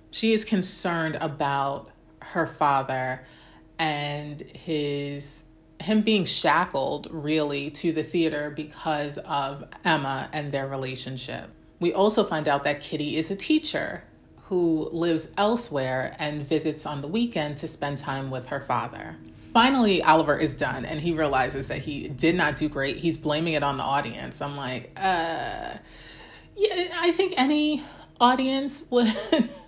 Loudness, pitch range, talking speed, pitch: -26 LUFS, 140-185 Hz, 145 wpm, 155 Hz